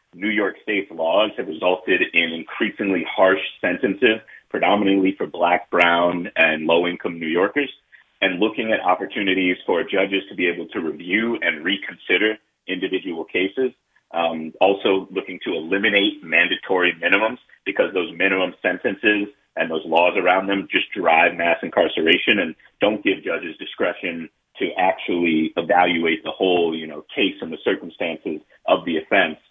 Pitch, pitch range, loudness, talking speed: 90 Hz, 85-95 Hz, -20 LUFS, 145 wpm